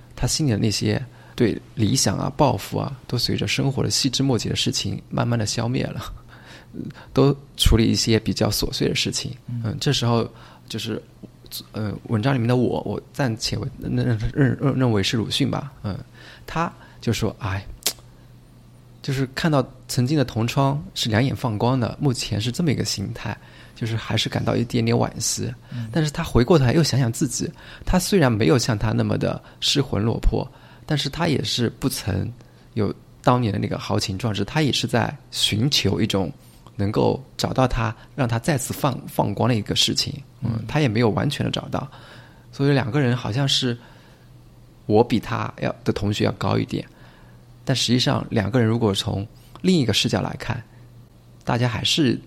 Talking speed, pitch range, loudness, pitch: 260 characters per minute, 110-135 Hz, -22 LUFS, 120 Hz